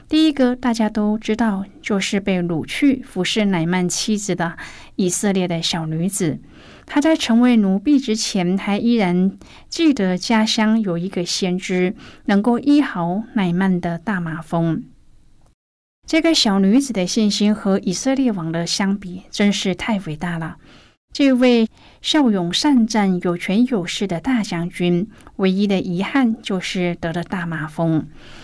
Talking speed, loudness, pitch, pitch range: 225 characters per minute, -19 LUFS, 195 Hz, 180-225 Hz